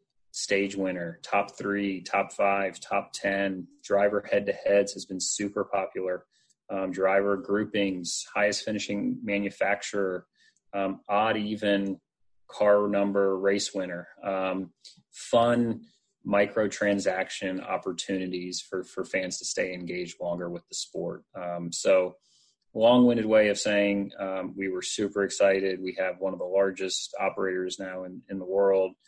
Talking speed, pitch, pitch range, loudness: 140 wpm, 100 Hz, 95-100 Hz, -28 LUFS